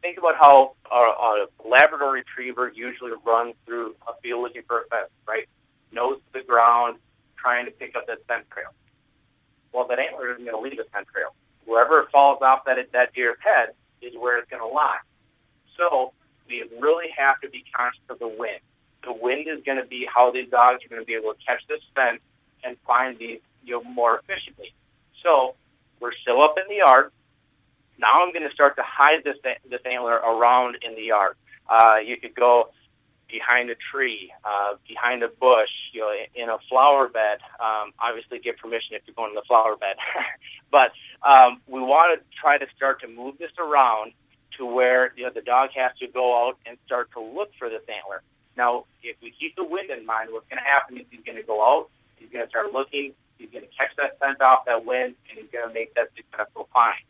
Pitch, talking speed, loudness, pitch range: 125 Hz, 215 wpm, -21 LUFS, 120-140 Hz